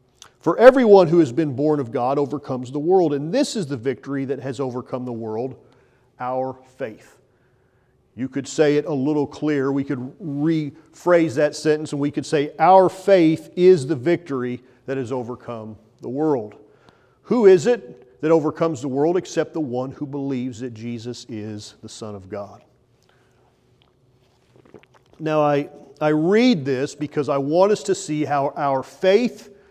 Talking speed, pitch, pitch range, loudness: 165 wpm, 140 Hz, 125-160 Hz, -20 LUFS